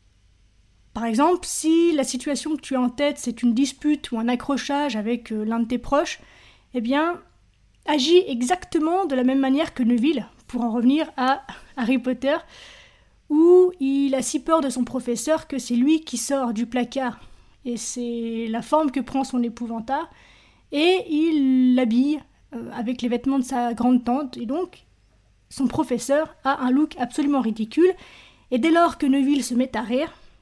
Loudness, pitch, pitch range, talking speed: -22 LUFS, 265 Hz, 245-300 Hz, 175 wpm